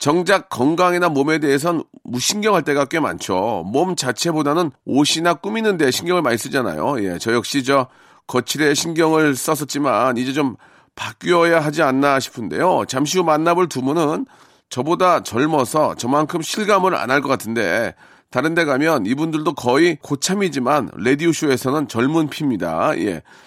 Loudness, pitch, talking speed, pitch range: -18 LUFS, 150 Hz, 330 characters per minute, 135-170 Hz